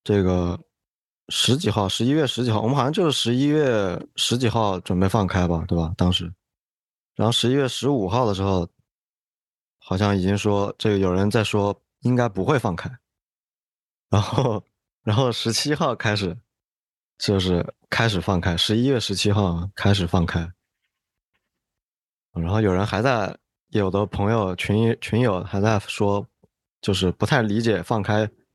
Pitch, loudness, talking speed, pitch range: 105 Hz, -22 LUFS, 230 characters per minute, 95-115 Hz